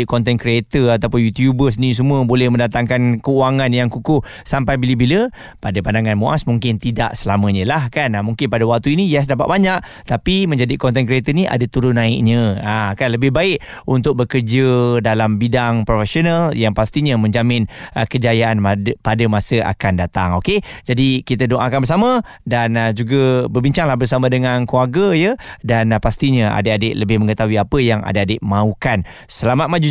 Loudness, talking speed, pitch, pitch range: -16 LUFS, 160 wpm, 120 Hz, 110-135 Hz